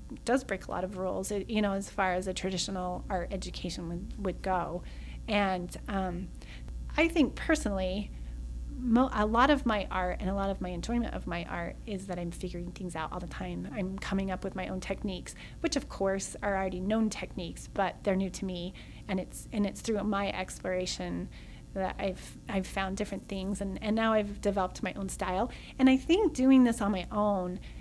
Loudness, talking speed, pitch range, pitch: -32 LUFS, 205 wpm, 185-210 Hz, 195 Hz